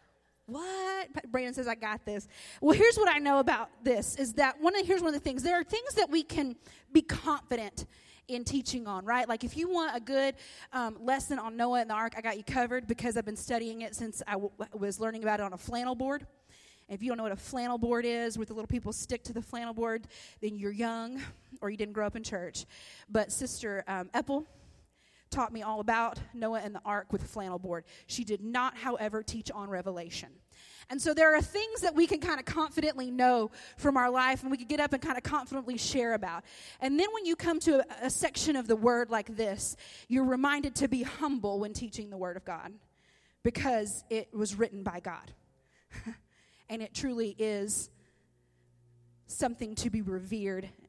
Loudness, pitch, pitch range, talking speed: -32 LUFS, 240 Hz, 215-275 Hz, 220 wpm